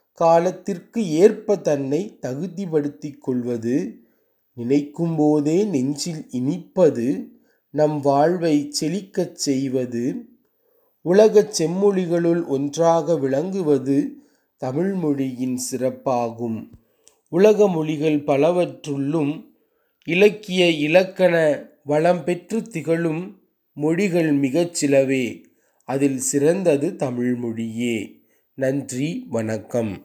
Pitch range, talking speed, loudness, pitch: 135-180 Hz, 70 wpm, -21 LUFS, 155 Hz